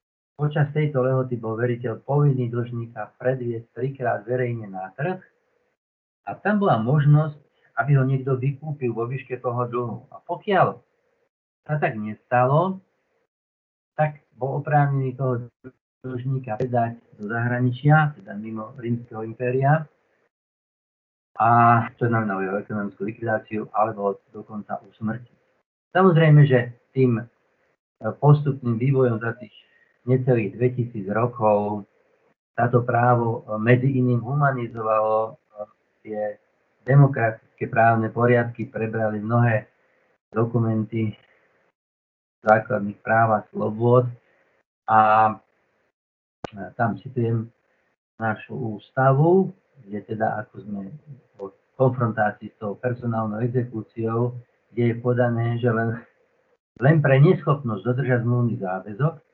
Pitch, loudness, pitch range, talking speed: 120 Hz, -22 LUFS, 110-135 Hz, 105 wpm